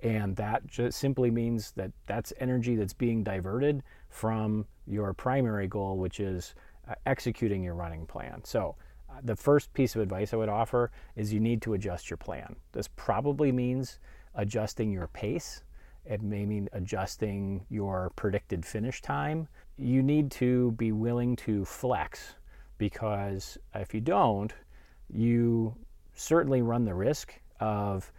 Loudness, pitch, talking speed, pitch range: -31 LUFS, 110 Hz, 145 wpm, 100-120 Hz